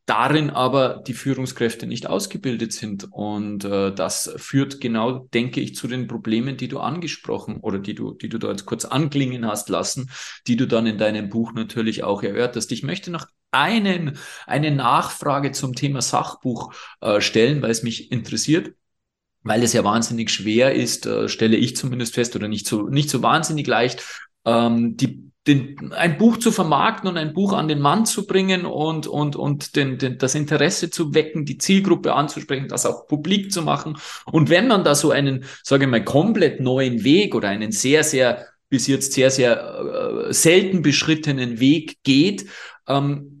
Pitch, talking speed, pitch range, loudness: 135 Hz, 180 wpm, 115-155 Hz, -20 LUFS